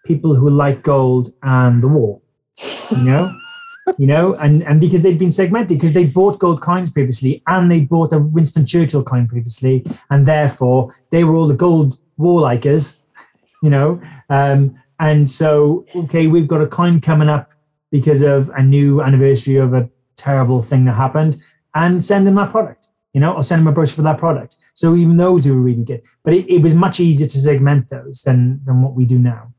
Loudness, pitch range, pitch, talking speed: -14 LUFS, 135-165 Hz, 150 Hz, 205 wpm